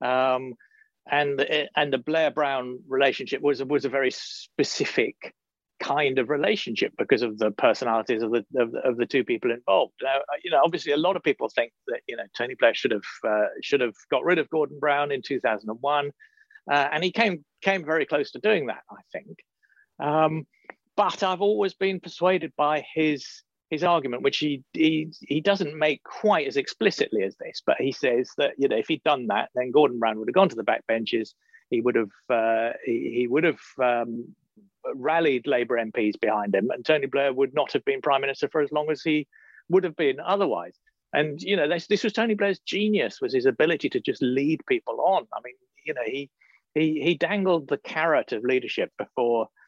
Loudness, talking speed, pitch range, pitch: -25 LUFS, 210 wpm, 135-210 Hz, 155 Hz